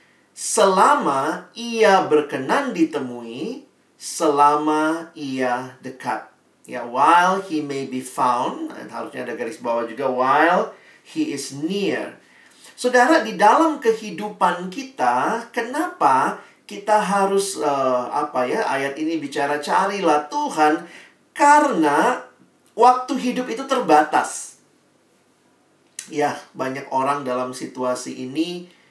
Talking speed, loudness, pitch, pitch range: 100 wpm, -20 LUFS, 160 Hz, 140-230 Hz